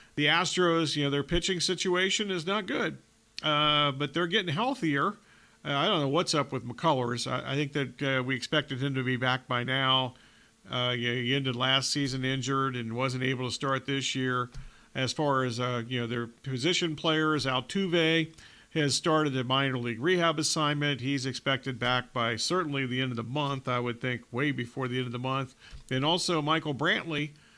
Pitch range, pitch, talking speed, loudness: 130-155 Hz, 135 Hz, 200 wpm, -28 LUFS